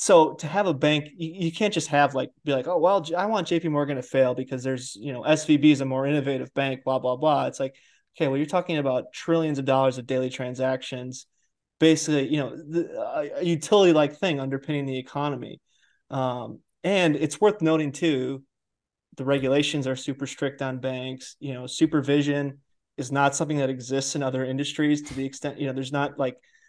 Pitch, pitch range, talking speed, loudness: 140 Hz, 130-155 Hz, 200 wpm, -25 LUFS